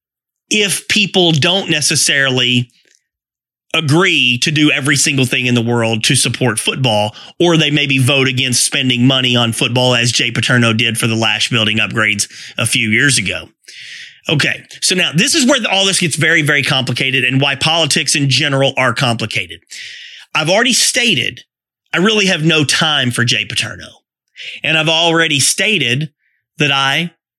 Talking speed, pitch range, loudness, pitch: 160 wpm, 120-160 Hz, -12 LUFS, 135 Hz